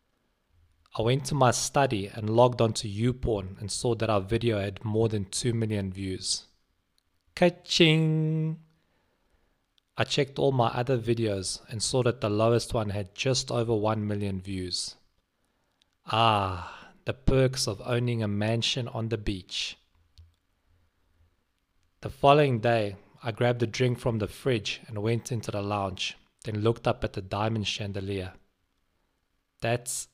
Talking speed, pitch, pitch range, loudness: 145 wpm, 110 Hz, 95-120 Hz, -28 LUFS